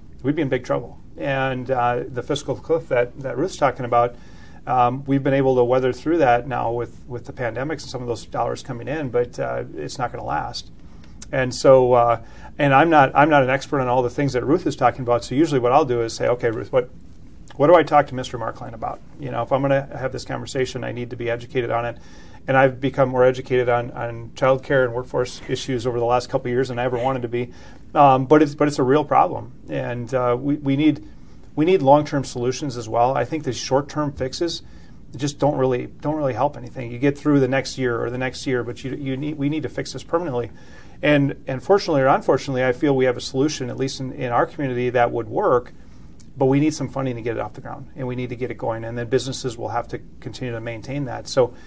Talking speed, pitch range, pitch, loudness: 255 wpm, 120-140 Hz, 130 Hz, -21 LUFS